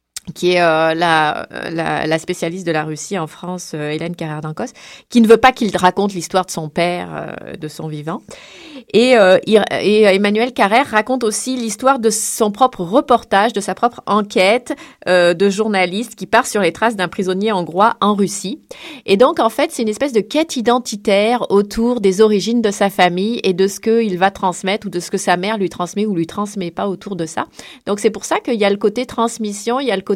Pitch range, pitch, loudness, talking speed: 180-230 Hz, 205 Hz, -16 LUFS, 225 wpm